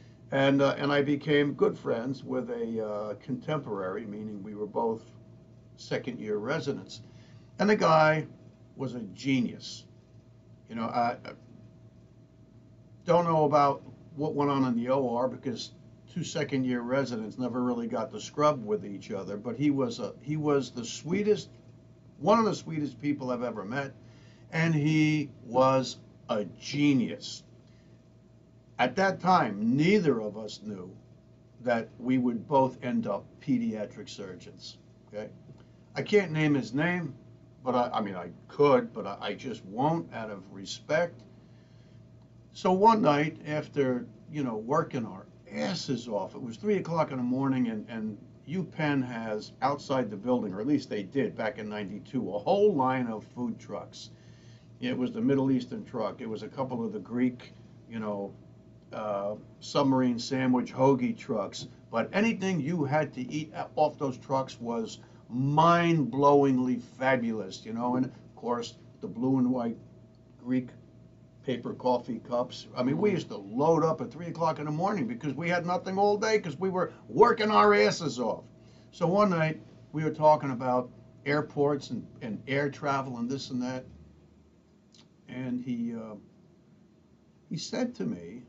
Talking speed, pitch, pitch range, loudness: 160 wpm, 130 Hz, 120-150 Hz, -29 LUFS